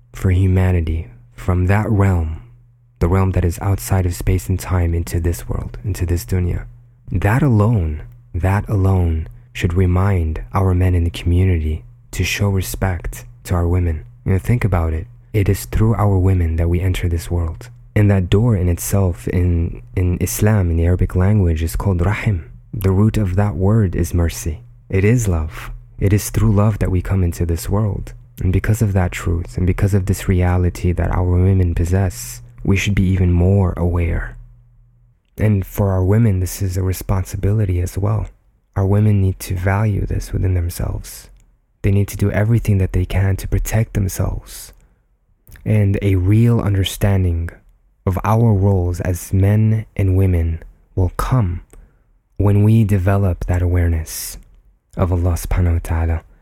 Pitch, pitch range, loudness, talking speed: 95 Hz, 90-105 Hz, -18 LUFS, 170 wpm